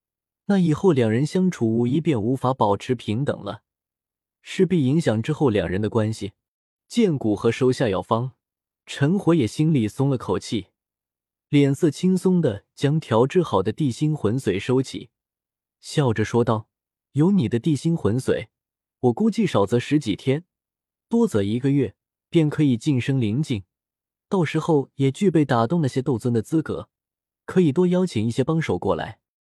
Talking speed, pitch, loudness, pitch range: 240 characters per minute, 135 Hz, -22 LUFS, 115-160 Hz